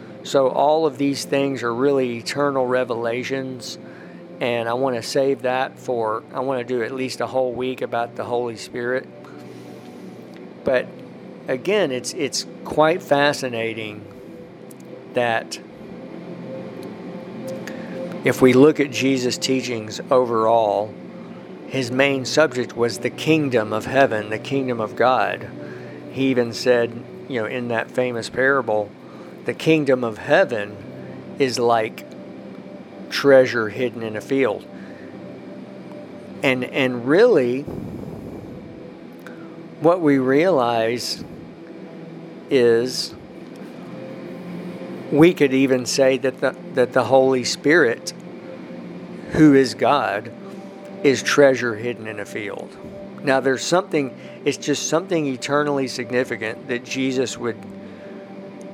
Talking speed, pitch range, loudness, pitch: 115 wpm, 115-135 Hz, -20 LUFS, 125 Hz